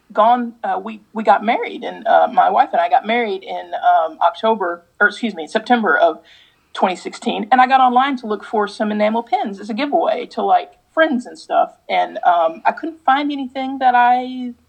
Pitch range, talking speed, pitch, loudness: 210-290 Hz, 200 wpm, 245 Hz, -17 LUFS